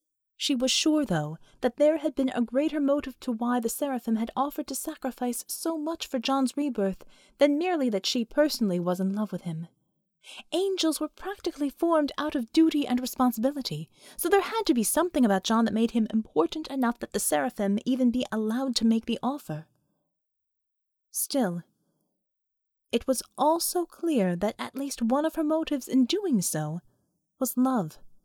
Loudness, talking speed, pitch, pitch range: -27 LUFS, 175 wpm, 255 Hz, 210-295 Hz